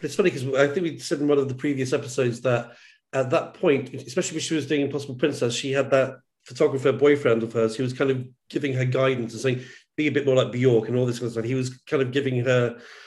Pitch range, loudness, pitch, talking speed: 125-145 Hz, -24 LUFS, 135 Hz, 265 wpm